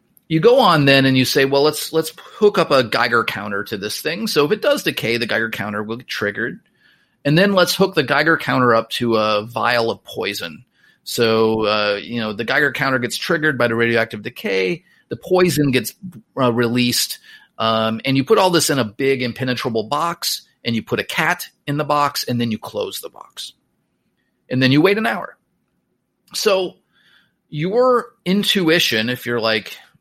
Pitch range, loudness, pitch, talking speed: 115-170 Hz, -18 LUFS, 135 Hz, 195 wpm